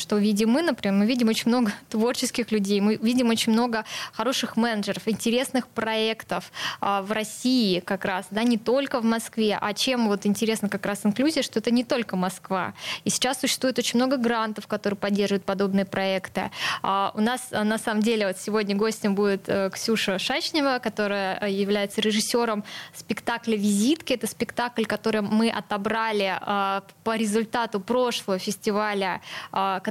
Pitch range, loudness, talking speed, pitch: 200-235 Hz, -25 LUFS, 150 wpm, 220 Hz